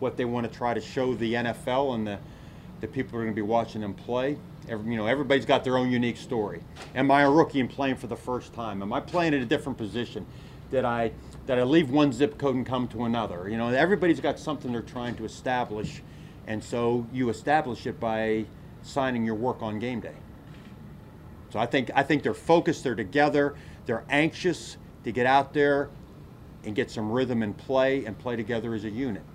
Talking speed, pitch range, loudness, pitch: 220 wpm, 115-140 Hz, -27 LUFS, 125 Hz